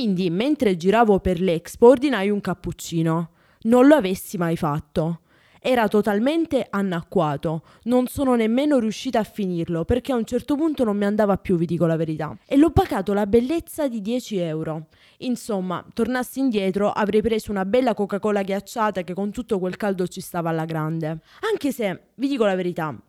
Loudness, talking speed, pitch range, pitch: -22 LUFS, 175 wpm, 175-245 Hz, 205 Hz